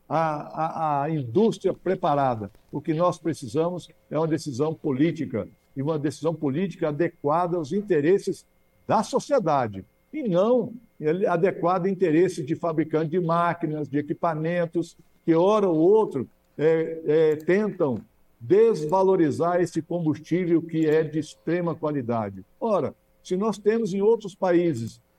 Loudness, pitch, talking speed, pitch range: -24 LUFS, 165 Hz, 130 wpm, 155-180 Hz